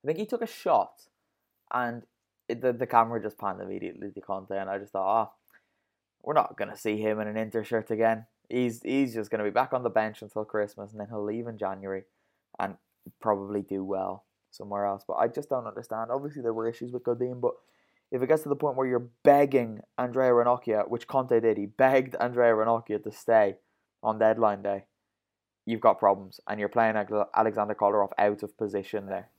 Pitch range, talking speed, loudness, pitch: 105-120 Hz, 210 wpm, -28 LUFS, 110 Hz